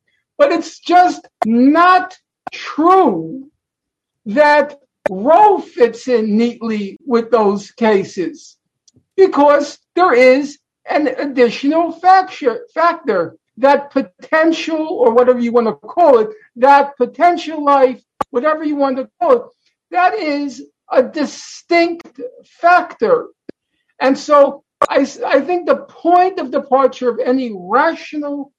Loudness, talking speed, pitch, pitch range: -14 LUFS, 115 wpm, 285 Hz, 255-340 Hz